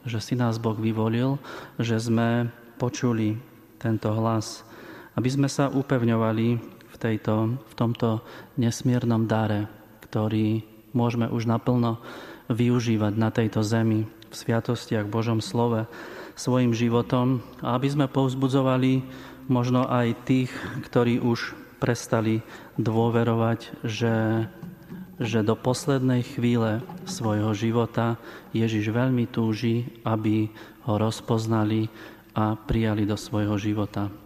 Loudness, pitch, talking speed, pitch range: -25 LUFS, 115 Hz, 110 wpm, 110-125 Hz